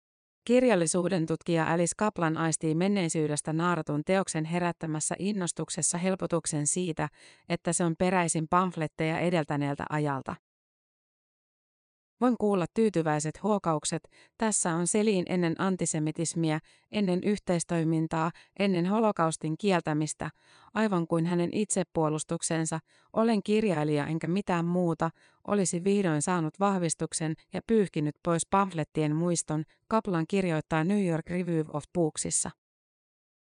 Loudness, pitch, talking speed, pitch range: -29 LUFS, 170 Hz, 105 wpm, 160-185 Hz